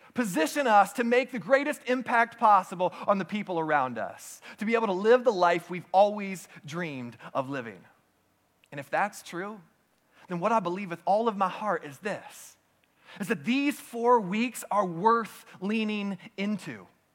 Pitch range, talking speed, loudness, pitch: 180-235 Hz, 170 wpm, -27 LUFS, 210 Hz